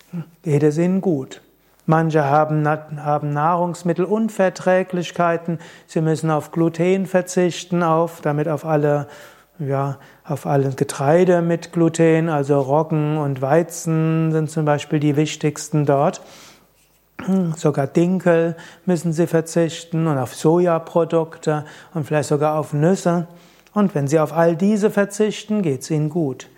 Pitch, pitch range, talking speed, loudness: 160 Hz, 150-175 Hz, 130 wpm, -19 LUFS